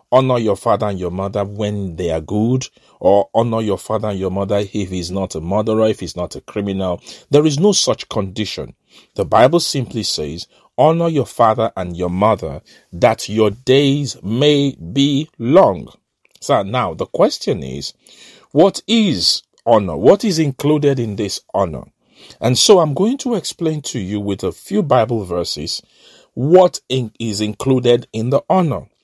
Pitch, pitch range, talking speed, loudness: 110 Hz, 100-140 Hz, 170 wpm, -16 LUFS